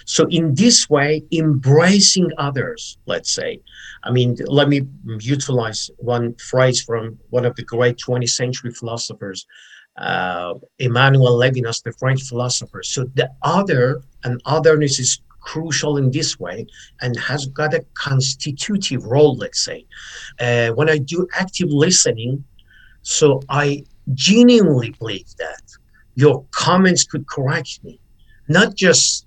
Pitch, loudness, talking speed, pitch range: 135 Hz, -17 LUFS, 135 wpm, 120-155 Hz